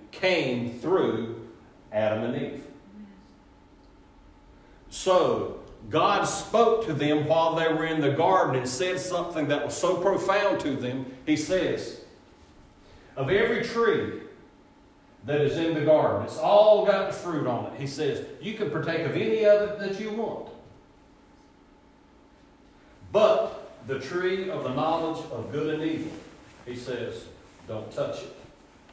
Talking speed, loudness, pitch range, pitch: 140 wpm, -26 LUFS, 140-210 Hz, 165 Hz